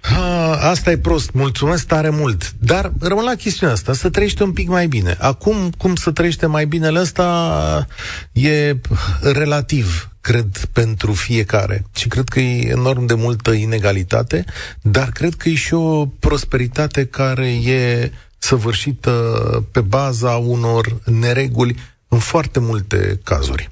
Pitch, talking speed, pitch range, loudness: 125 Hz, 140 wpm, 115-155 Hz, -17 LUFS